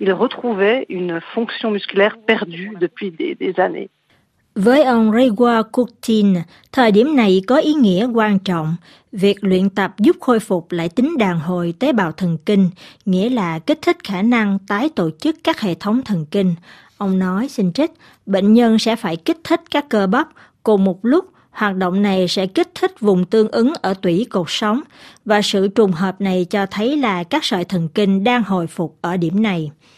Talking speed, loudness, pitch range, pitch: 175 wpm, -17 LUFS, 185-240 Hz, 205 Hz